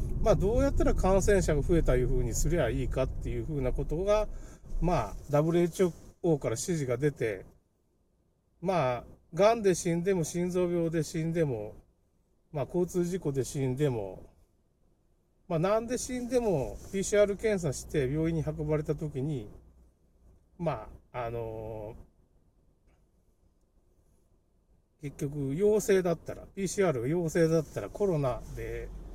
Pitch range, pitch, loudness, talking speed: 110-175 Hz, 150 Hz, -30 LUFS, 245 characters per minute